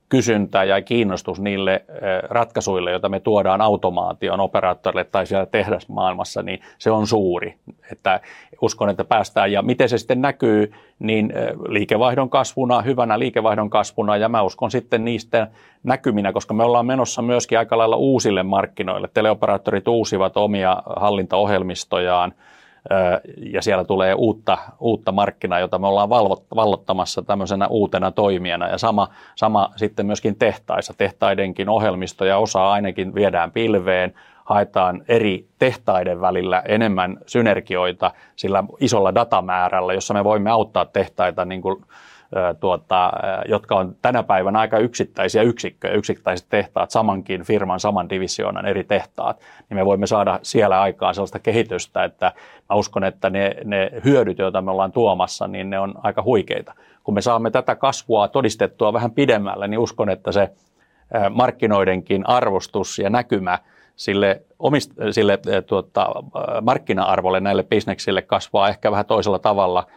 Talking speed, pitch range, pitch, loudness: 135 wpm, 95-110 Hz, 100 Hz, -19 LUFS